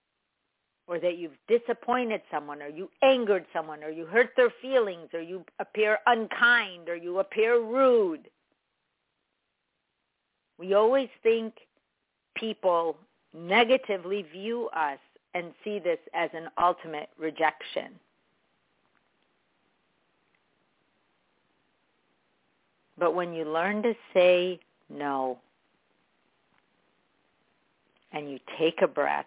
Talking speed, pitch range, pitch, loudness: 100 wpm, 165-230 Hz, 185 Hz, -27 LUFS